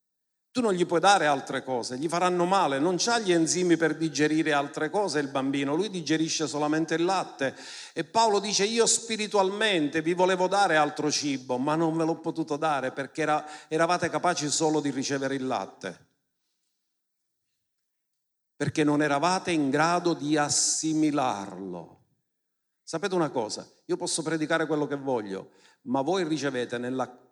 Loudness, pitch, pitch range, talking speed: -26 LUFS, 155 Hz, 145-175 Hz, 155 wpm